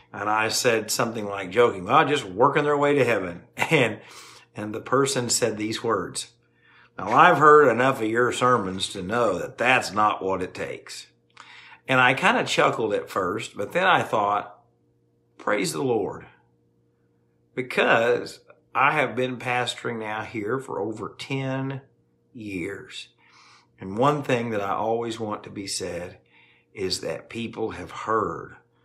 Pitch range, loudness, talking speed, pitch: 95-125 Hz, -23 LUFS, 155 wpm, 110 Hz